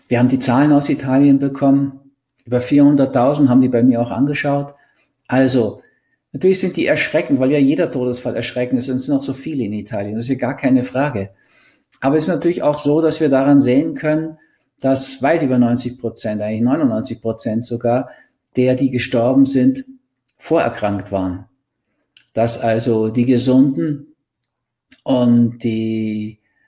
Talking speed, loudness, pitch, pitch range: 160 wpm, -17 LUFS, 130 Hz, 120-140 Hz